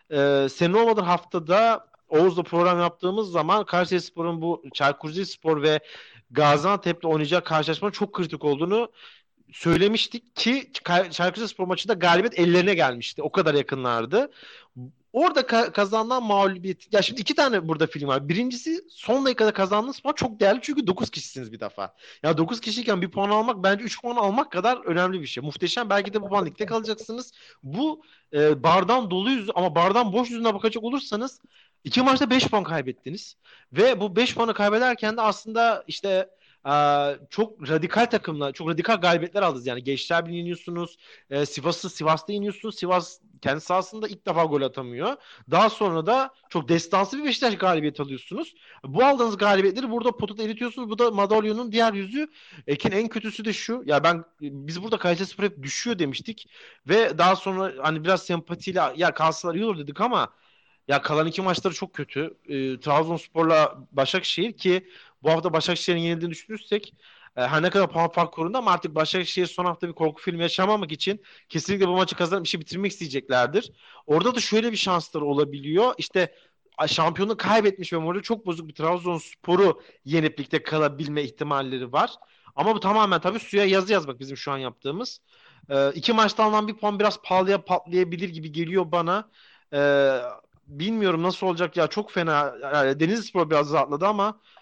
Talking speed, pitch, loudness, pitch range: 165 wpm, 185 Hz, -24 LUFS, 160-215 Hz